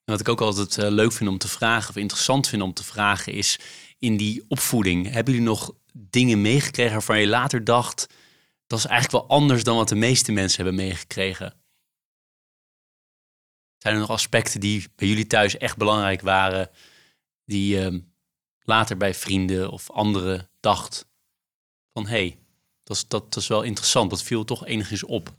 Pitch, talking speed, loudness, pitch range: 105 Hz, 175 wpm, -22 LUFS, 95-115 Hz